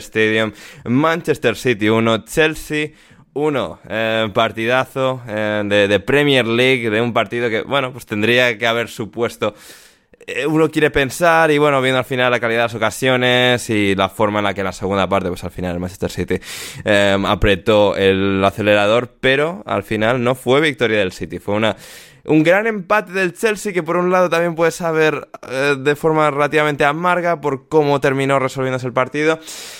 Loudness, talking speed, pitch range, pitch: -16 LUFS, 180 wpm, 110-150 Hz, 125 Hz